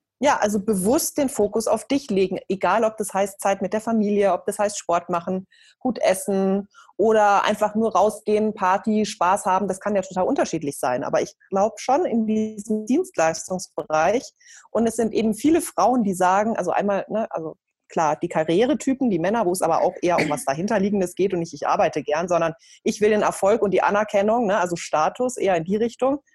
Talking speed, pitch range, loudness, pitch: 205 wpm, 185-220 Hz, -22 LUFS, 205 Hz